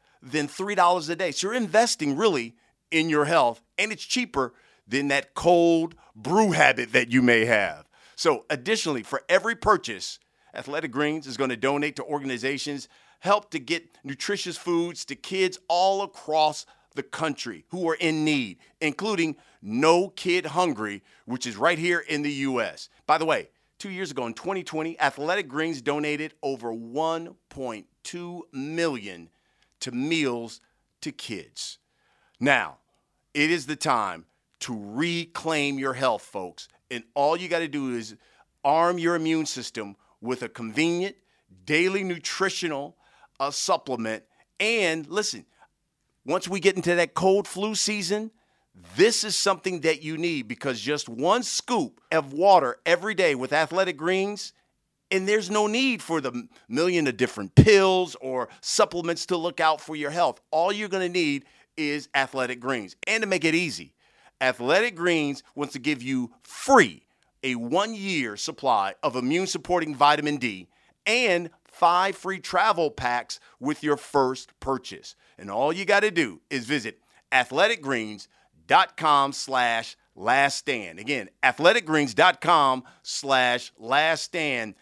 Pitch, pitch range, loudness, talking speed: 160 Hz, 135-185 Hz, -25 LUFS, 145 wpm